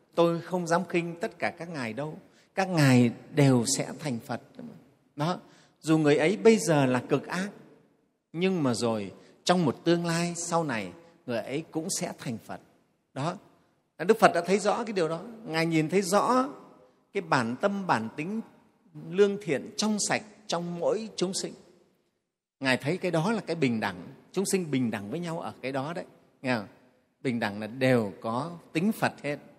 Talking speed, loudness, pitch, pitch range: 190 wpm, -28 LUFS, 165 Hz, 130-185 Hz